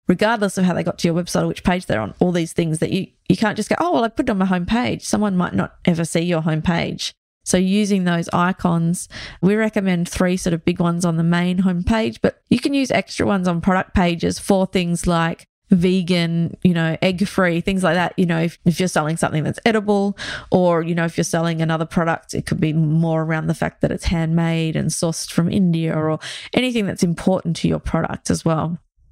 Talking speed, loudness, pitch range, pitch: 230 wpm, -19 LUFS, 165-190 Hz, 175 Hz